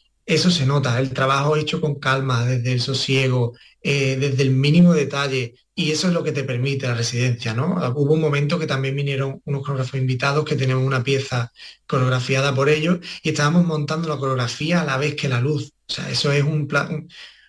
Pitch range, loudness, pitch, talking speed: 130-150 Hz, -20 LUFS, 140 Hz, 200 wpm